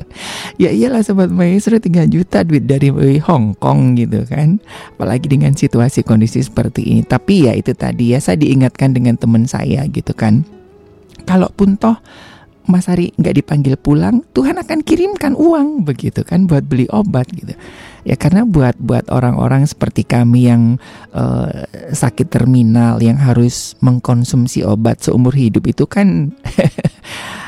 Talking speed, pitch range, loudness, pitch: 145 wpm, 120-180 Hz, -13 LUFS, 135 Hz